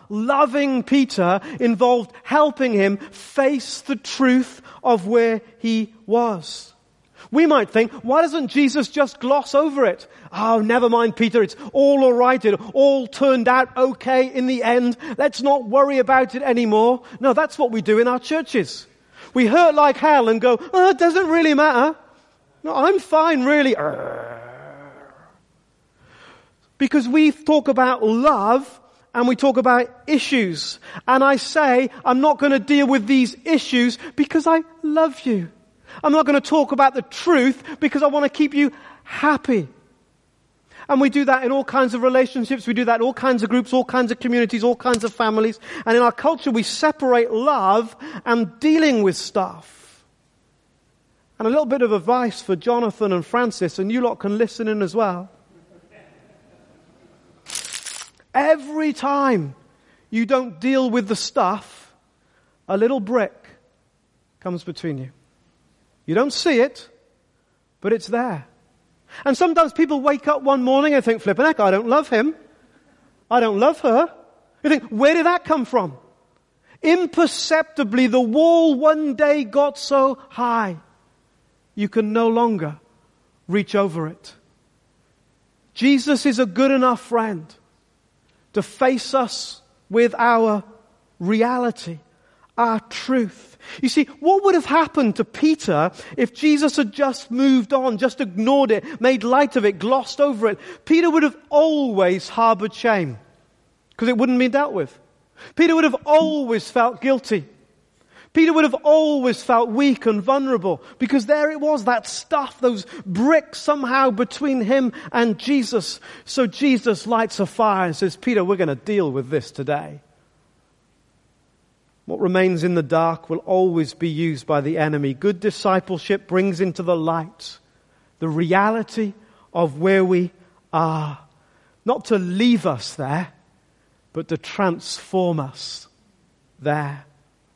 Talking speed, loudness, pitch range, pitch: 150 wpm, -19 LUFS, 210-280 Hz, 245 Hz